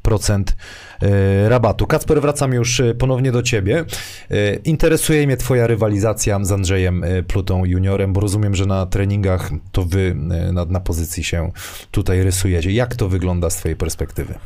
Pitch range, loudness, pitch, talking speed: 90-115 Hz, -18 LUFS, 100 Hz, 145 wpm